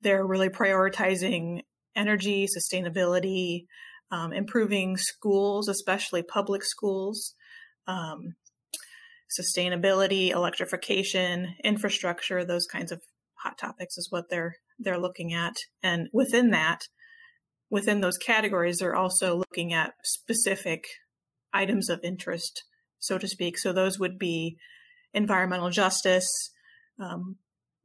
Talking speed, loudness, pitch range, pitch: 110 wpm, -27 LUFS, 180-210 Hz, 190 Hz